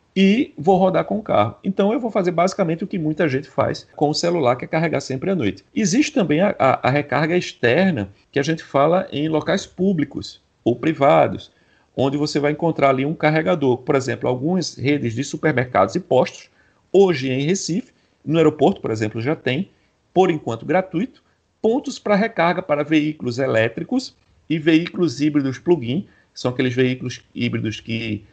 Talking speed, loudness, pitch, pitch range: 180 wpm, -20 LUFS, 155 Hz, 130-185 Hz